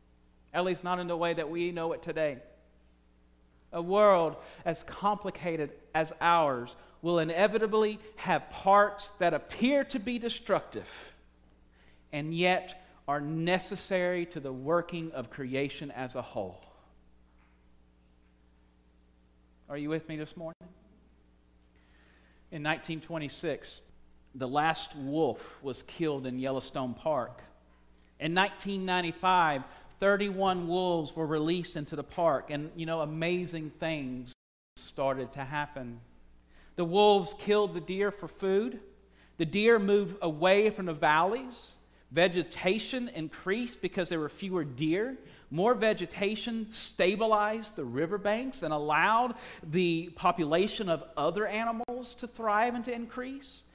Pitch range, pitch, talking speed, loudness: 130-200 Hz, 165 Hz, 120 wpm, -30 LUFS